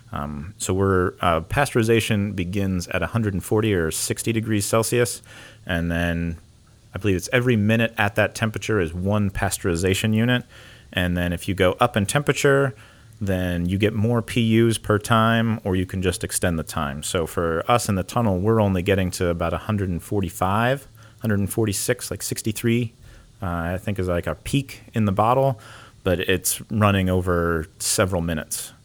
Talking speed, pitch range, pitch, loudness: 185 wpm, 90-115 Hz, 105 Hz, -22 LUFS